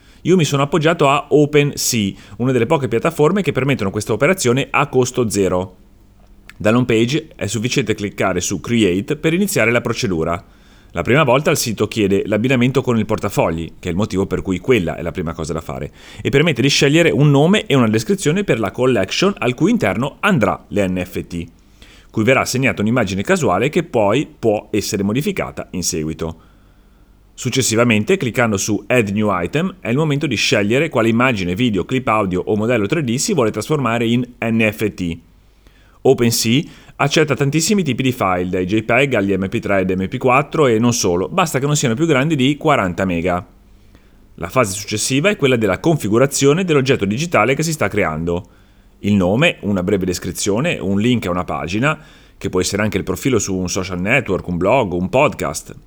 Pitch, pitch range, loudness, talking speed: 110 Hz, 95-135 Hz, -17 LUFS, 175 wpm